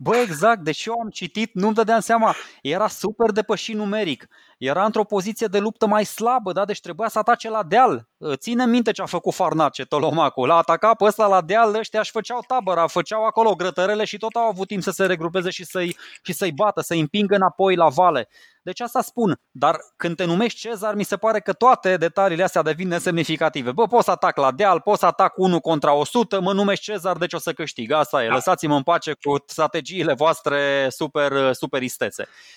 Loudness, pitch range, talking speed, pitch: -20 LUFS, 165-220 Hz, 205 wpm, 190 Hz